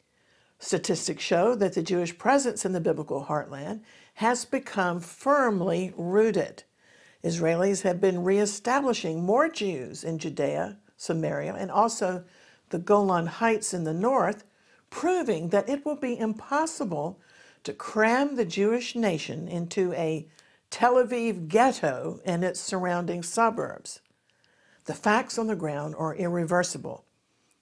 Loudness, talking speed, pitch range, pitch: -27 LUFS, 125 wpm, 175-230 Hz, 195 Hz